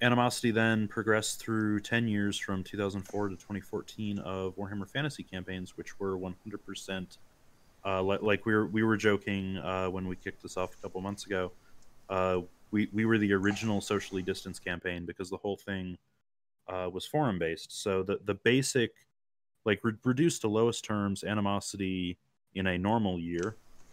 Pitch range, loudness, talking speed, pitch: 95-105 Hz, -32 LUFS, 170 wpm, 100 Hz